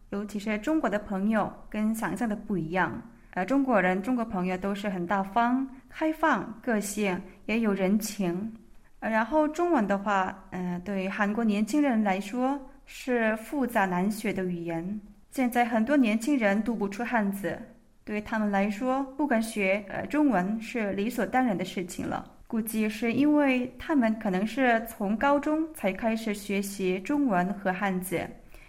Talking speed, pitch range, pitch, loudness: 245 characters per minute, 195-245 Hz, 215 Hz, -28 LUFS